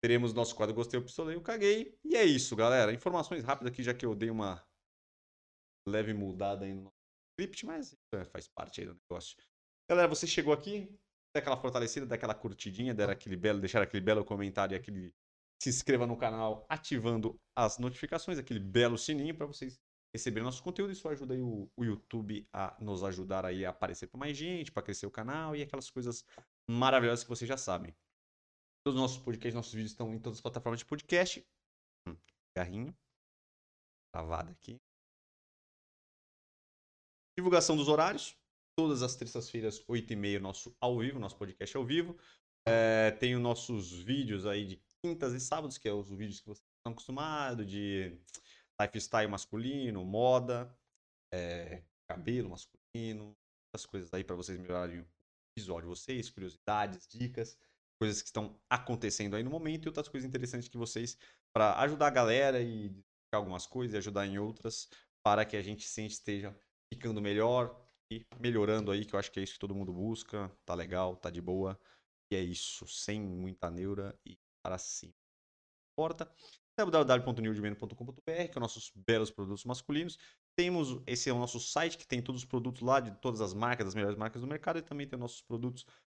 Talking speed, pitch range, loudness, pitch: 180 wpm, 100-130 Hz, -35 LUFS, 115 Hz